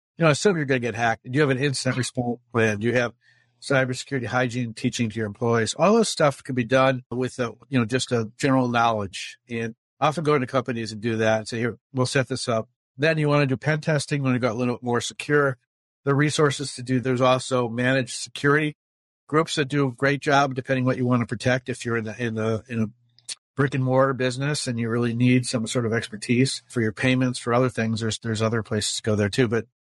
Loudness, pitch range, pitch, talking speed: -23 LUFS, 115-135 Hz, 125 Hz, 250 wpm